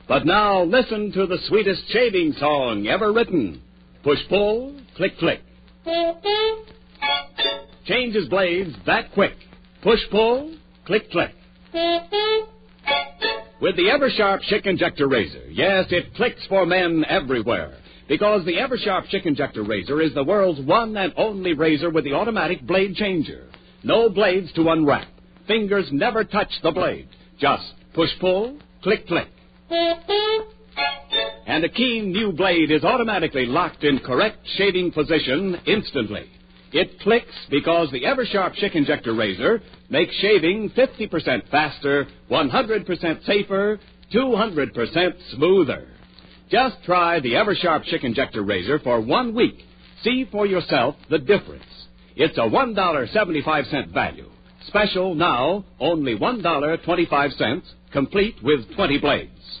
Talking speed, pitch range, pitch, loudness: 125 wpm, 150-220 Hz, 185 Hz, -21 LUFS